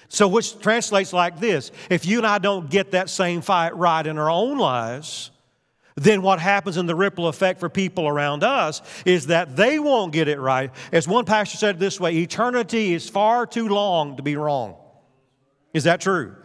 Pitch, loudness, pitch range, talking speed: 180 Hz, -21 LUFS, 150-205 Hz, 195 wpm